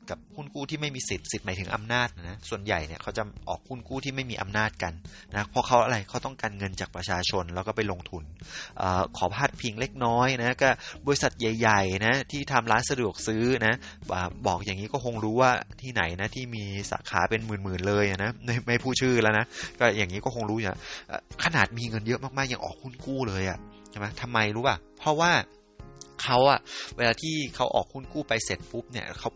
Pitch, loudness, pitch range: 110 Hz, -28 LUFS, 100-125 Hz